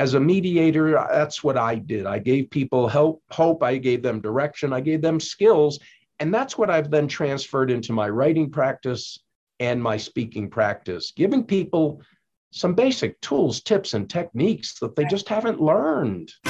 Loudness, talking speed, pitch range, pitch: -22 LUFS, 170 wpm, 125-165 Hz, 145 Hz